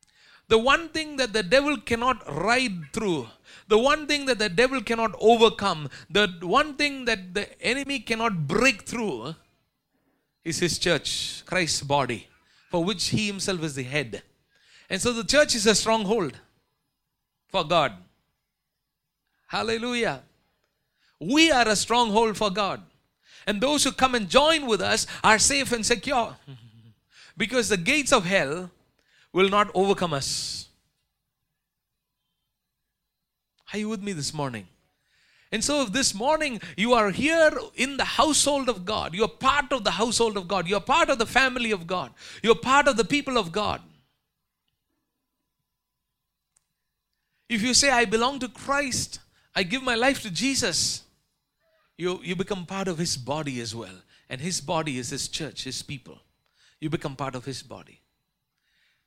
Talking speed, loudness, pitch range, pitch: 155 wpm, -24 LUFS, 175-255 Hz, 215 Hz